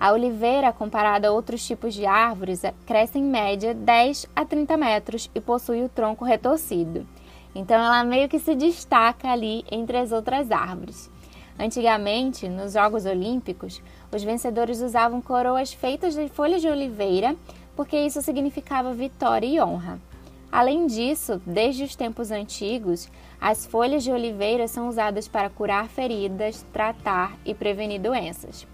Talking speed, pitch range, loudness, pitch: 145 wpm, 210-255 Hz, -24 LUFS, 230 Hz